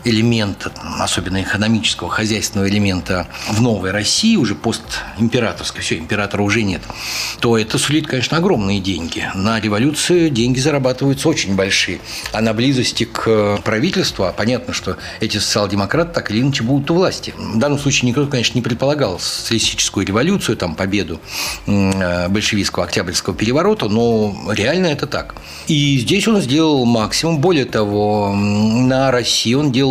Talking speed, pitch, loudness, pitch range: 140 wpm, 115 Hz, -16 LUFS, 100-135 Hz